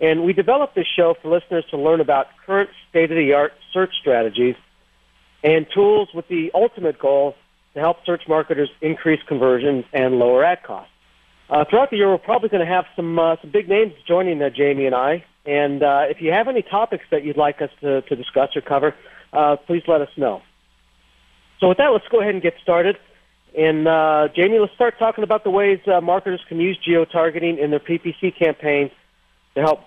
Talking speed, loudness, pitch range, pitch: 200 wpm, -19 LUFS, 145-180 Hz, 160 Hz